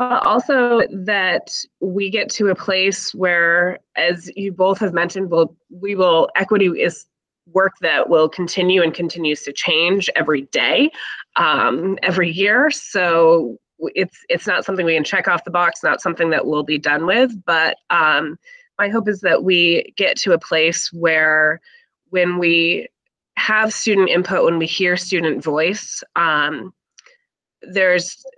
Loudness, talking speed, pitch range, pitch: -17 LUFS, 155 wpm, 170-200 Hz, 185 Hz